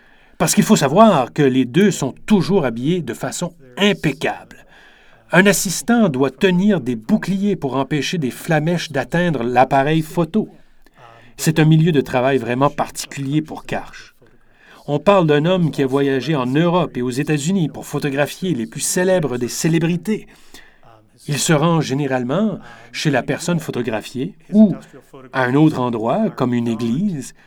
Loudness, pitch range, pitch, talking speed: -18 LUFS, 130-180 Hz, 150 Hz, 155 wpm